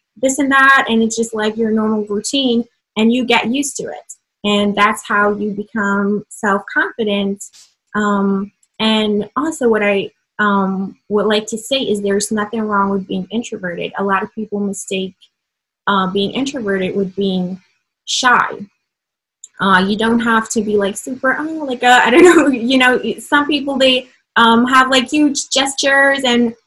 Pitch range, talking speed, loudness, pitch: 200-250 Hz, 170 wpm, -15 LUFS, 220 Hz